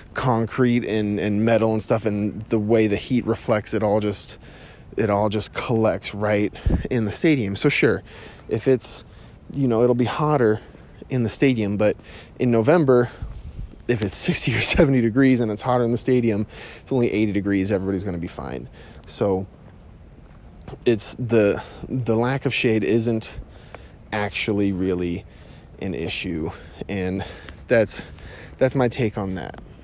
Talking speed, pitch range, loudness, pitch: 155 wpm, 100-120 Hz, -22 LUFS, 110 Hz